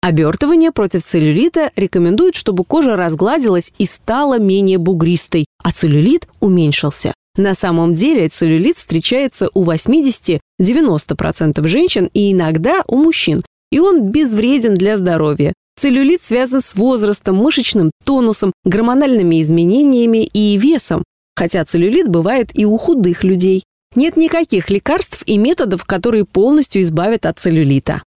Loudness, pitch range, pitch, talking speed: -13 LUFS, 170-265 Hz, 200 Hz, 125 wpm